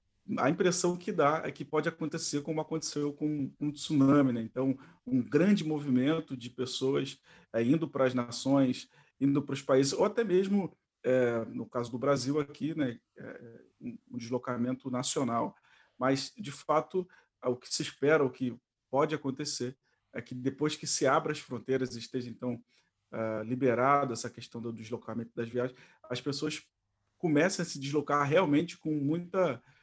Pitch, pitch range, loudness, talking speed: 135 Hz, 125-155 Hz, -31 LUFS, 165 wpm